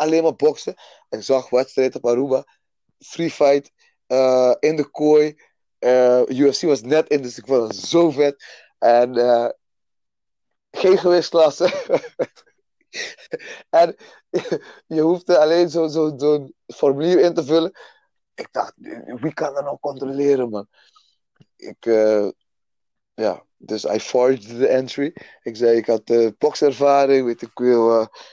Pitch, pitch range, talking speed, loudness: 140 Hz, 125-160 Hz, 150 wpm, -19 LUFS